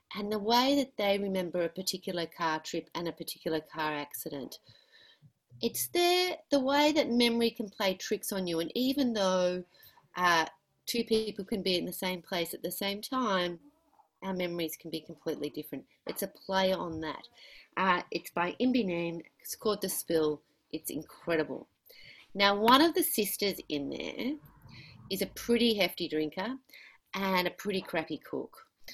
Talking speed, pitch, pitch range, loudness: 170 wpm, 190 Hz, 170-235 Hz, -31 LUFS